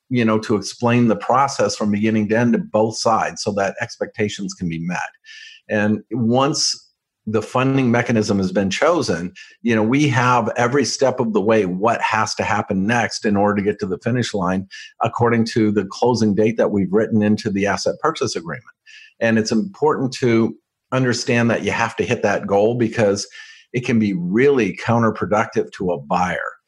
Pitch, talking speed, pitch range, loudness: 110 Hz, 185 wpm, 105-120 Hz, -19 LUFS